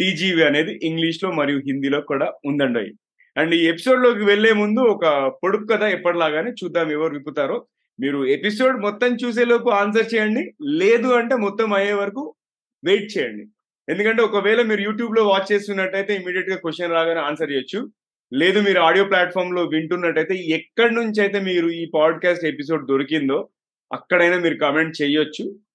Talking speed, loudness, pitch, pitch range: 155 wpm, -19 LUFS, 185 Hz, 160-215 Hz